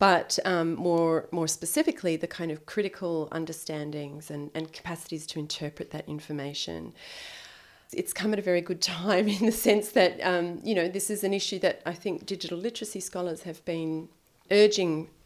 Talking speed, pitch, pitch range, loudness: 175 wpm, 170 Hz, 160-195 Hz, -28 LUFS